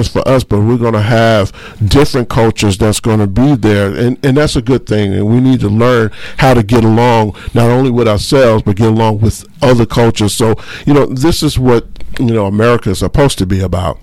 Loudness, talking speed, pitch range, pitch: -11 LUFS, 225 wpm, 105-125 Hz, 115 Hz